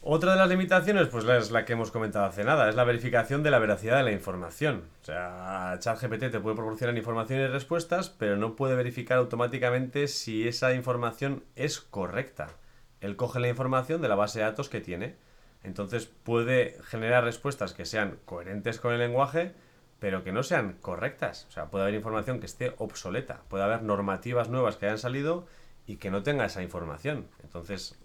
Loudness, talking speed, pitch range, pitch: -29 LUFS, 190 wpm, 105-130 Hz, 120 Hz